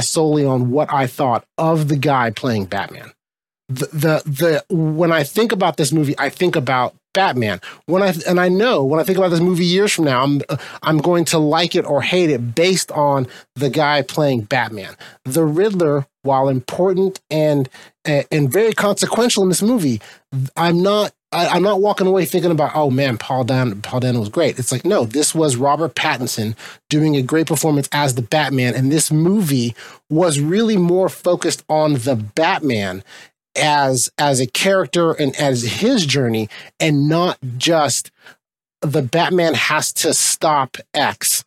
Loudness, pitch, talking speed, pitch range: -17 LUFS, 150 Hz, 170 wpm, 135-175 Hz